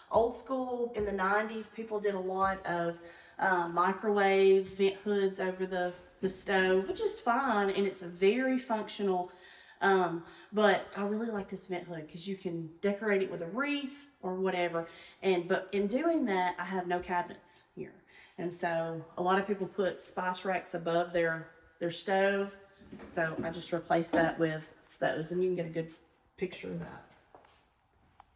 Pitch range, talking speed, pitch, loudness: 175-200 Hz, 175 wpm, 185 Hz, -32 LUFS